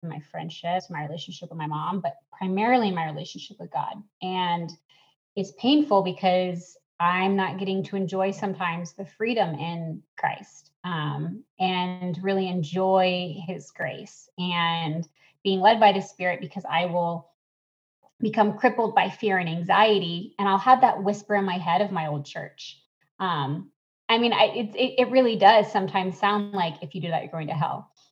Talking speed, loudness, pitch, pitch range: 170 wpm, -25 LUFS, 185 Hz, 170-205 Hz